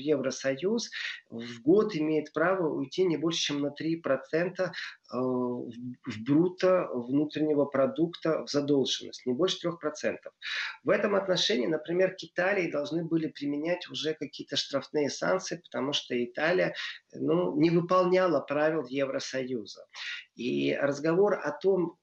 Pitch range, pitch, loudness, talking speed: 135-175 Hz, 155 Hz, -29 LUFS, 125 wpm